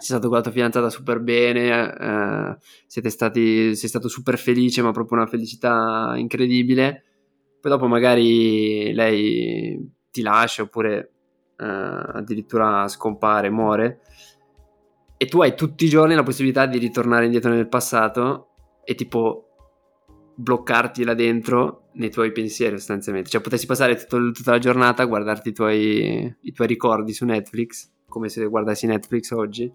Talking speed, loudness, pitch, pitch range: 150 wpm, -20 LUFS, 115 Hz, 110-125 Hz